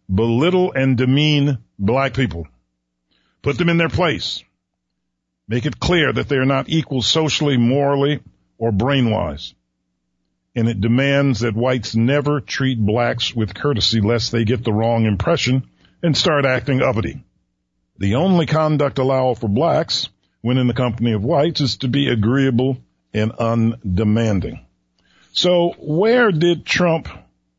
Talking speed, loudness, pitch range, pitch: 140 wpm, -18 LUFS, 105-140 Hz, 120 Hz